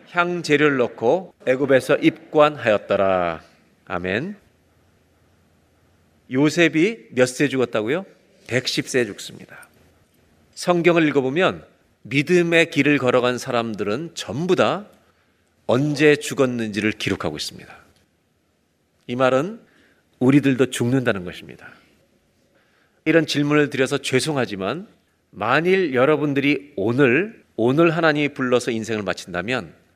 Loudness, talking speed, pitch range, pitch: -20 LUFS, 245 characters per minute, 110-150 Hz, 130 Hz